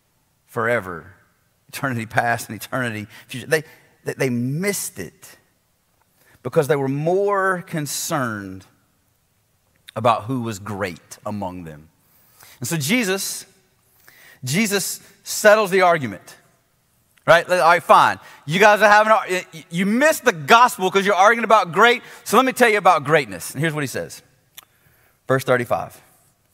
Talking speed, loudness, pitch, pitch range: 135 wpm, -18 LUFS, 135 Hz, 125-190 Hz